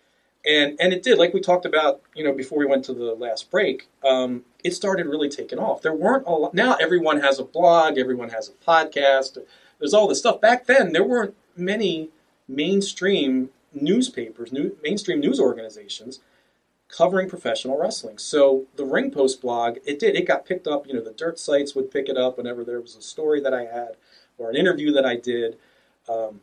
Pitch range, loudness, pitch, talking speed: 130-175 Hz, -22 LUFS, 140 Hz, 200 wpm